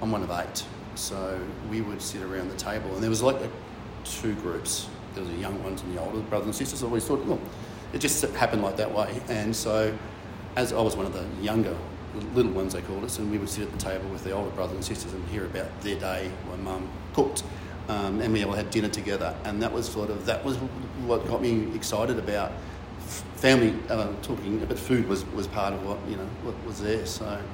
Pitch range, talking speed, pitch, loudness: 95-110 Hz, 240 wpm, 105 Hz, -29 LUFS